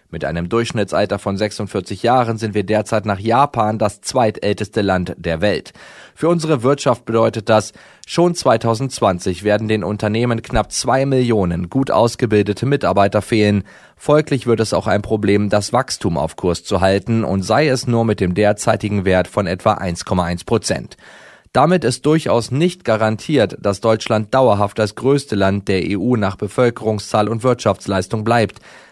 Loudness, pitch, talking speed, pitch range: -17 LUFS, 110 Hz, 155 wpm, 100-120 Hz